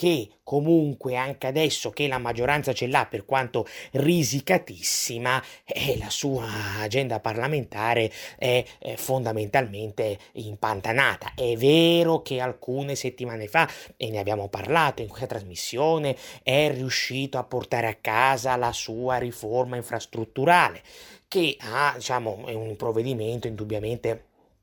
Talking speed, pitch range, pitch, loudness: 120 wpm, 115-135 Hz, 125 Hz, -25 LUFS